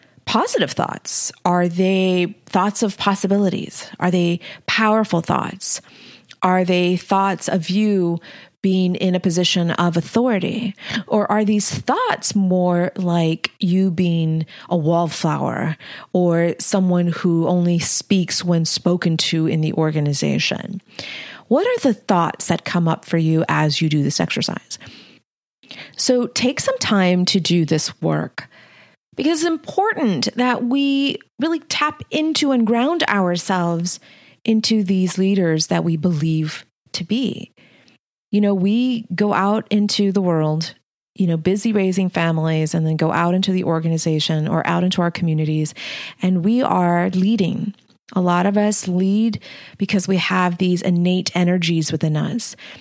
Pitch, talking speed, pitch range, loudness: 185 Hz, 145 wpm, 170-205 Hz, -19 LUFS